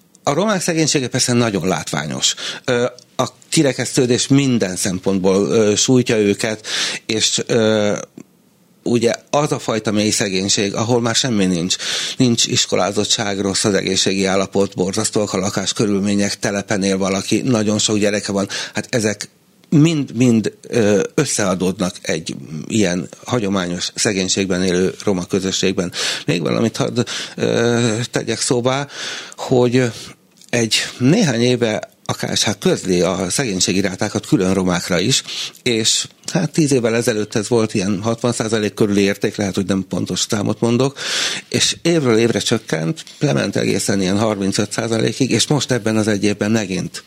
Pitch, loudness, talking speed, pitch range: 110 Hz, -17 LUFS, 125 wpm, 100-125 Hz